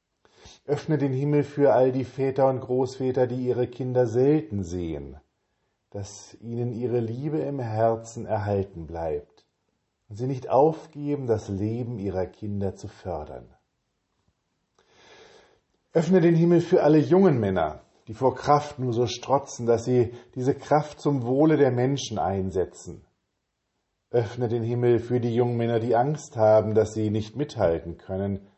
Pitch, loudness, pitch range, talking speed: 120 Hz, -25 LUFS, 105-140 Hz, 145 wpm